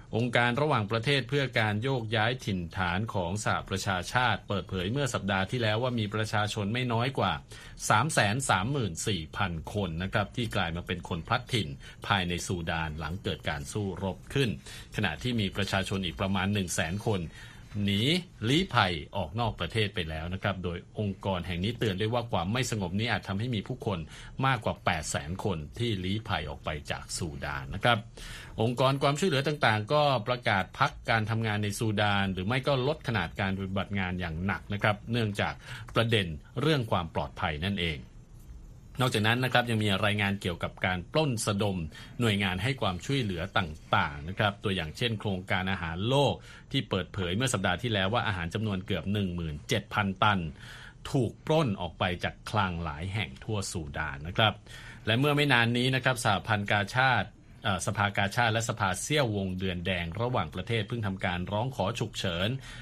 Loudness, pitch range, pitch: -30 LUFS, 95-120 Hz, 105 Hz